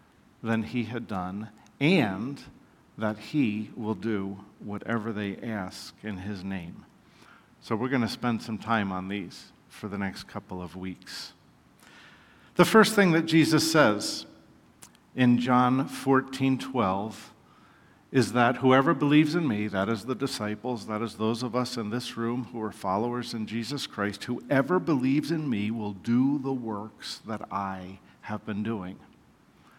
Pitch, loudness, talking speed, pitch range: 115 Hz, -27 LUFS, 155 wpm, 105-130 Hz